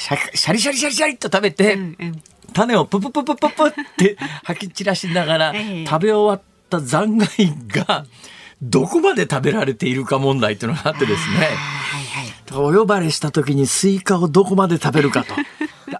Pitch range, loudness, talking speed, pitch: 150-210 Hz, -18 LUFS, 340 characters per minute, 190 Hz